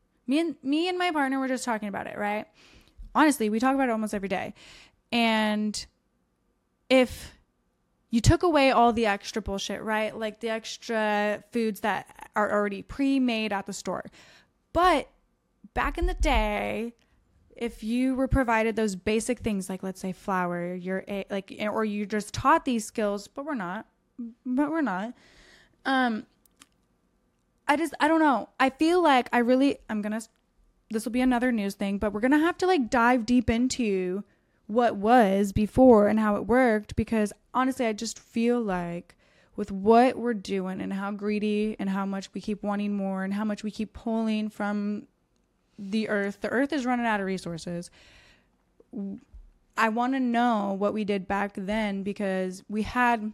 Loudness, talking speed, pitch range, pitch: -26 LUFS, 175 wpm, 205-250 Hz, 220 Hz